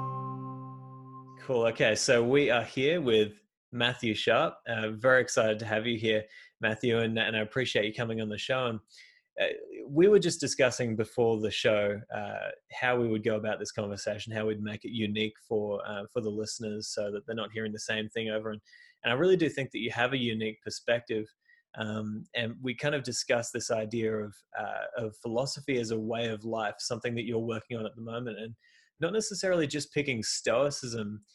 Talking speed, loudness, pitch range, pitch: 200 wpm, -30 LUFS, 110-130 Hz, 115 Hz